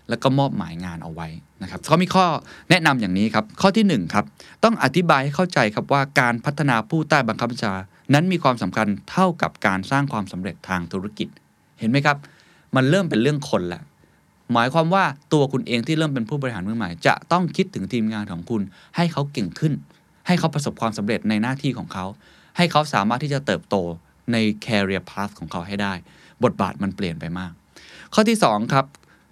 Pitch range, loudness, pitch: 100-155 Hz, -21 LUFS, 130 Hz